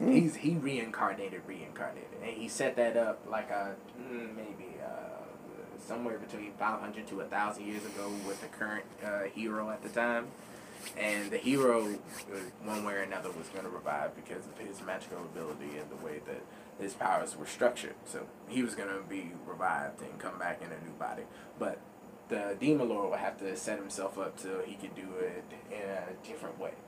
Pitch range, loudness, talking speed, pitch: 100-120 Hz, -36 LUFS, 190 wpm, 105 Hz